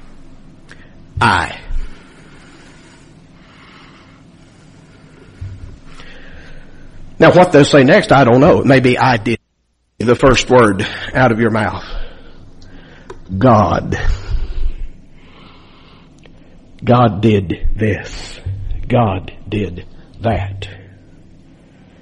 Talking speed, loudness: 70 wpm, -13 LUFS